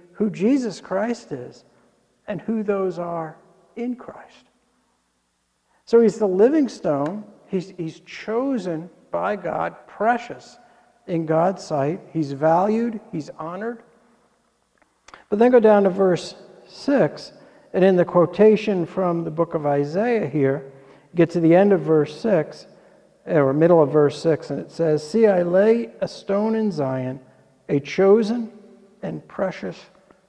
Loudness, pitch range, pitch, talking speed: -21 LUFS, 160-220 Hz, 190 Hz, 145 wpm